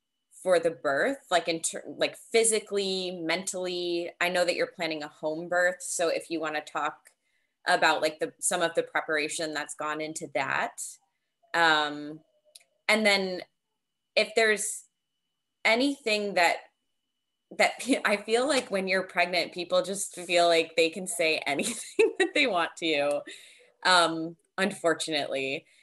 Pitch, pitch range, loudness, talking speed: 175 Hz, 160-205 Hz, -27 LUFS, 145 wpm